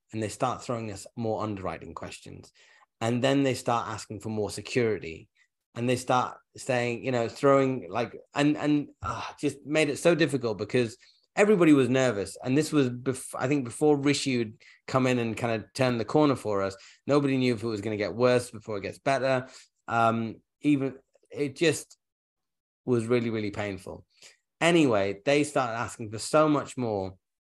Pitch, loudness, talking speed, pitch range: 125 Hz, -27 LUFS, 185 wpm, 110-140 Hz